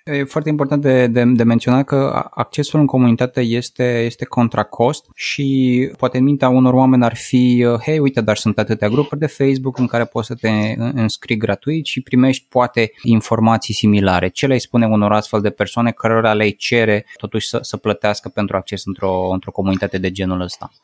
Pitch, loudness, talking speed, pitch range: 120 Hz, -16 LUFS, 185 wpm, 105-130 Hz